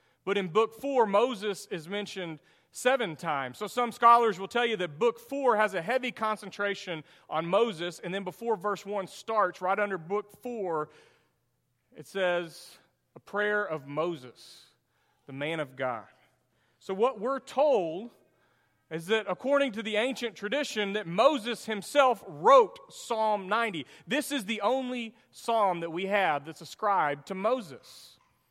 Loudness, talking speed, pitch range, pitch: -29 LUFS, 155 wpm, 180-235 Hz, 205 Hz